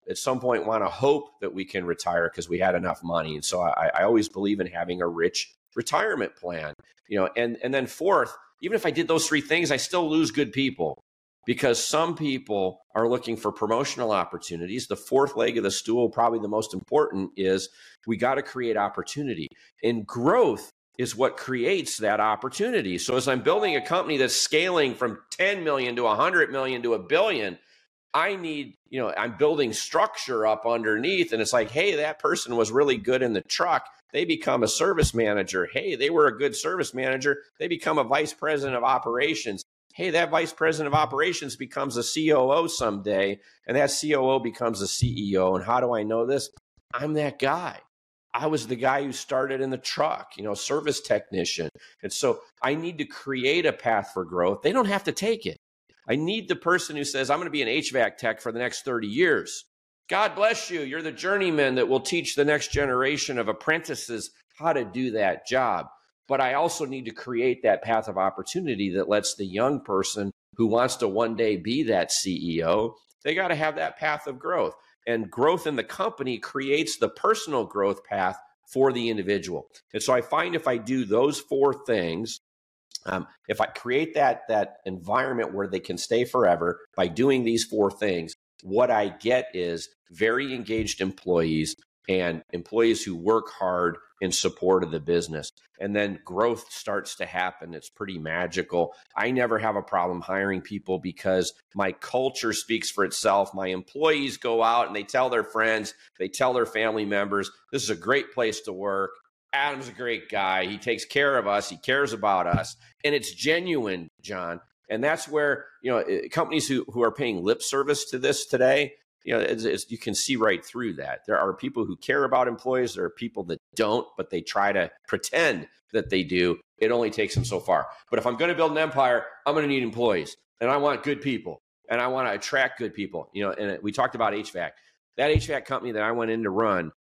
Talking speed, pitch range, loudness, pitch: 205 wpm, 100-150 Hz, -26 LUFS, 125 Hz